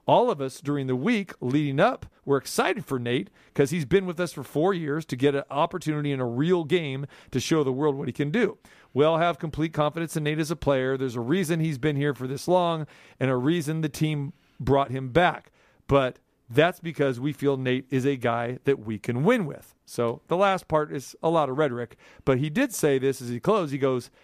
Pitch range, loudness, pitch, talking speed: 135-165 Hz, -26 LUFS, 145 Hz, 240 wpm